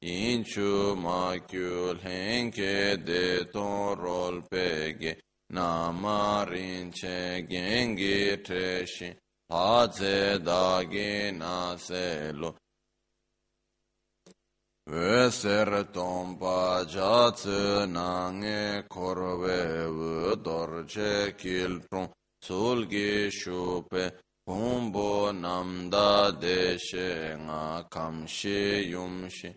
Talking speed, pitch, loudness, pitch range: 40 wpm, 90 Hz, -29 LUFS, 90-100 Hz